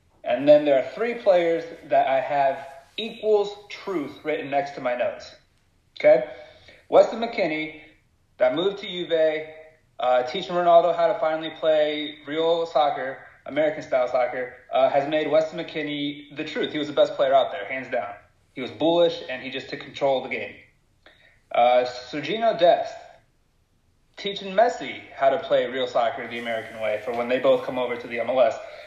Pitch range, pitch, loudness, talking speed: 140-215 Hz, 160 Hz, -23 LUFS, 175 wpm